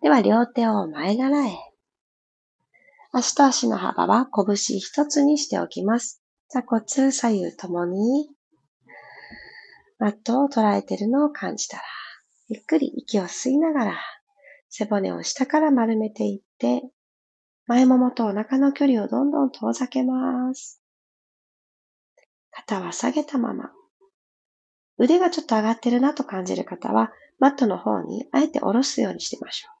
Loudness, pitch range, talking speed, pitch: -22 LUFS, 220-285 Hz, 275 characters per minute, 255 Hz